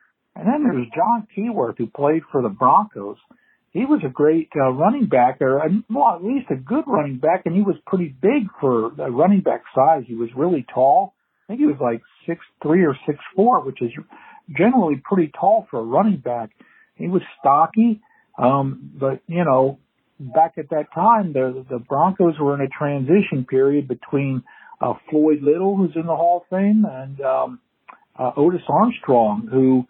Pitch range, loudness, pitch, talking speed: 135-200 Hz, -19 LUFS, 160 Hz, 190 wpm